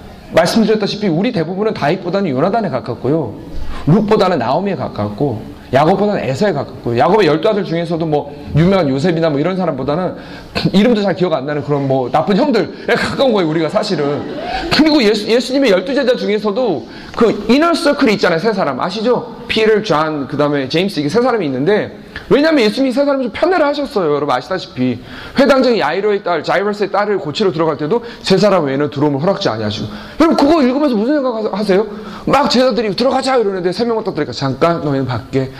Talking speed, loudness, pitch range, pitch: 445 characters per minute, -14 LUFS, 150-230 Hz, 195 Hz